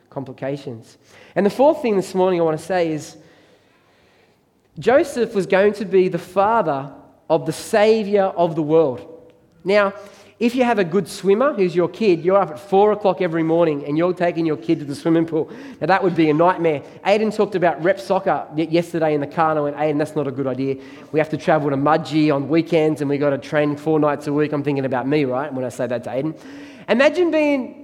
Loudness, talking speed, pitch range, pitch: -19 LUFS, 225 wpm, 150-195 Hz, 165 Hz